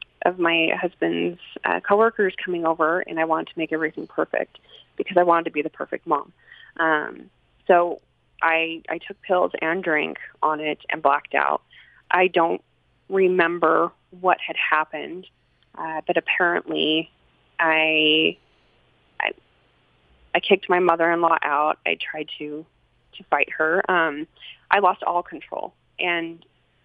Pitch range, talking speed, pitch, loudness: 155-180 Hz, 145 wpm, 165 Hz, -22 LUFS